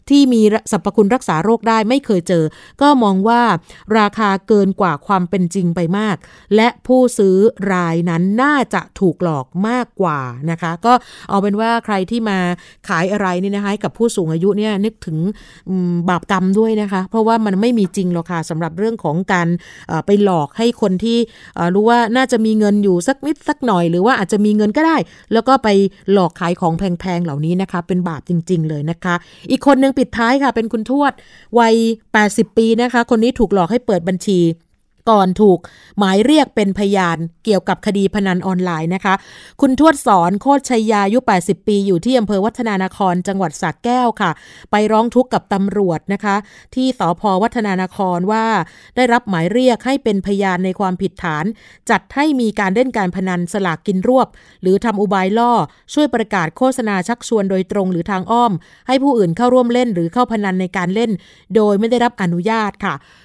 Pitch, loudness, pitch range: 200 Hz, -16 LUFS, 185-230 Hz